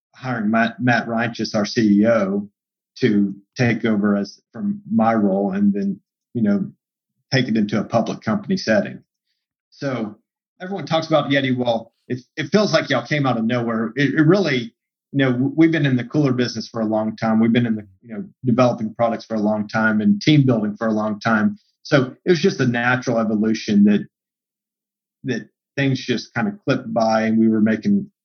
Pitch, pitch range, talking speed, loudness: 125 Hz, 110-165 Hz, 195 wpm, -19 LUFS